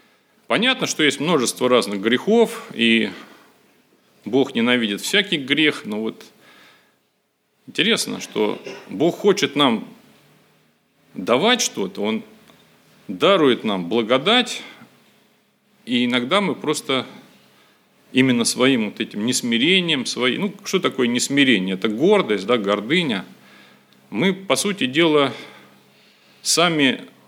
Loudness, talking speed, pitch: -19 LUFS, 105 wpm, 145 Hz